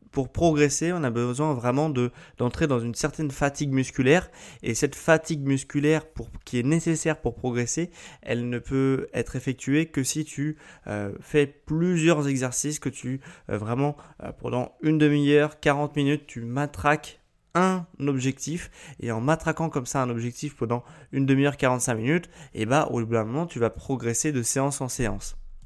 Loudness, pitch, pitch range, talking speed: -26 LUFS, 140 Hz, 125-155 Hz, 175 wpm